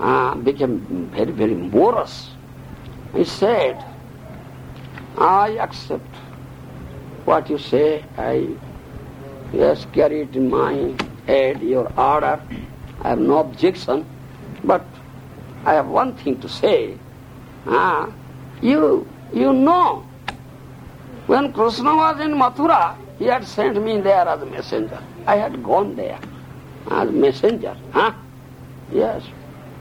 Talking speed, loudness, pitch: 120 wpm, -19 LUFS, 260 Hz